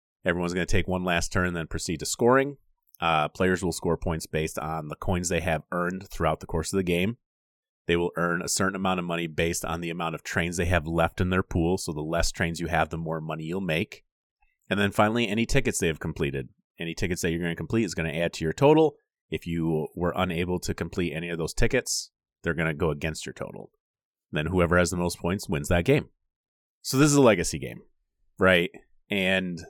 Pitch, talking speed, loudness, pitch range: 85 Hz, 240 wpm, -26 LUFS, 80-95 Hz